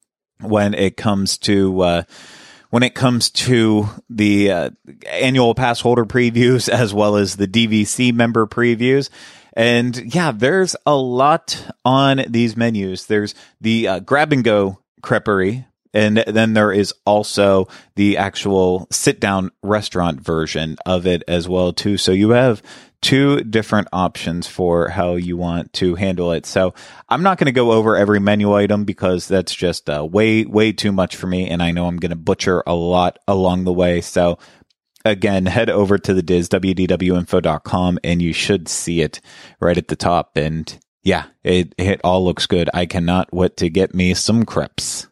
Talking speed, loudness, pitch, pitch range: 170 wpm, -17 LUFS, 100 Hz, 90-115 Hz